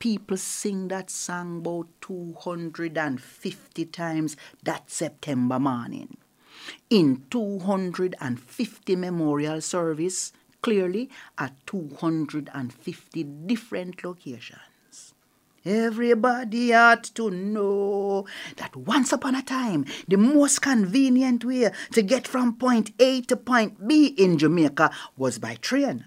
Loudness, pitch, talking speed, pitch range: -24 LUFS, 190 Hz, 105 wpm, 165-235 Hz